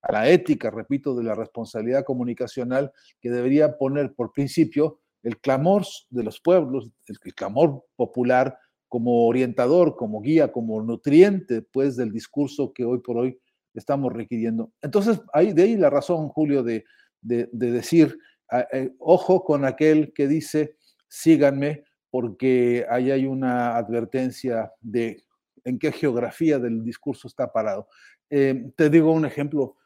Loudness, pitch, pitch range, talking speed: -22 LUFS, 130 Hz, 120-150 Hz, 145 wpm